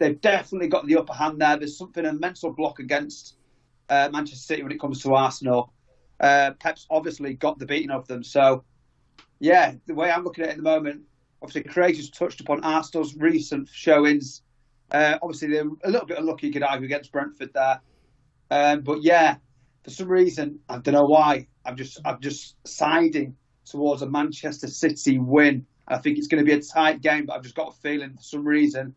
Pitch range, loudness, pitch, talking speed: 135-160 Hz, -23 LUFS, 145 Hz, 205 wpm